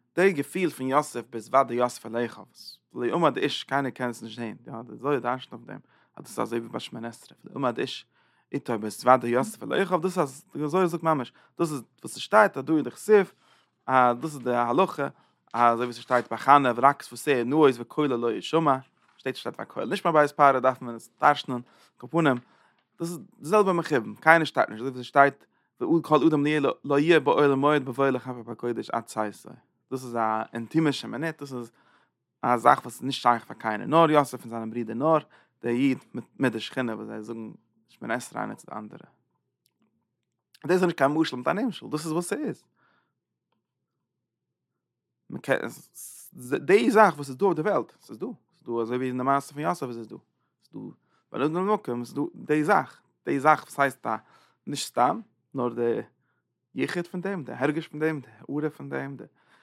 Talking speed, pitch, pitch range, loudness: 200 wpm, 135 Hz, 120-155 Hz, -25 LUFS